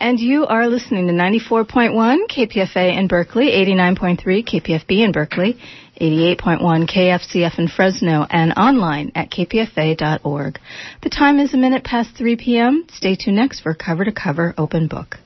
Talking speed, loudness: 150 wpm, -16 LUFS